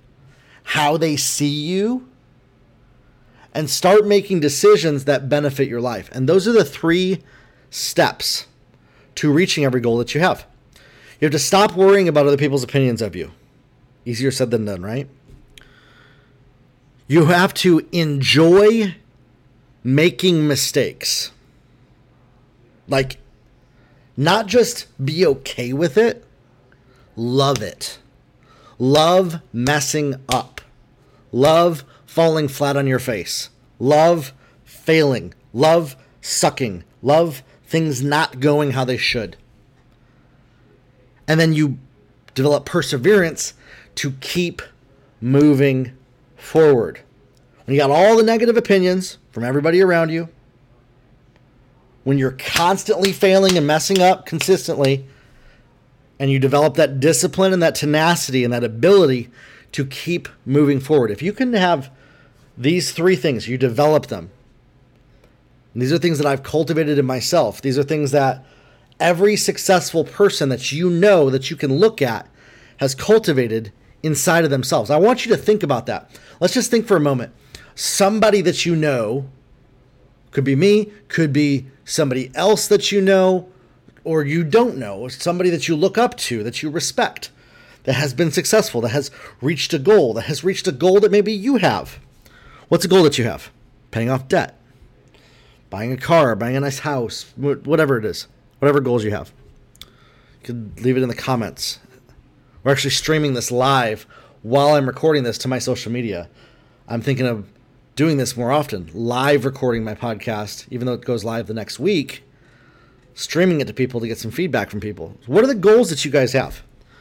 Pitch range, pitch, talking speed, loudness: 125-165 Hz, 140 Hz, 150 wpm, -17 LUFS